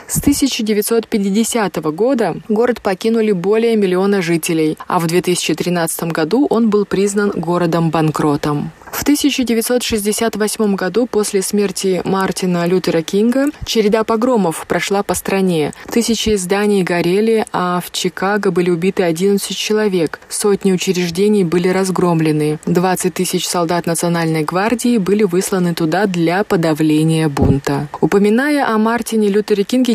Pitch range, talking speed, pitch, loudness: 175-215 Hz, 120 wpm, 195 Hz, -15 LUFS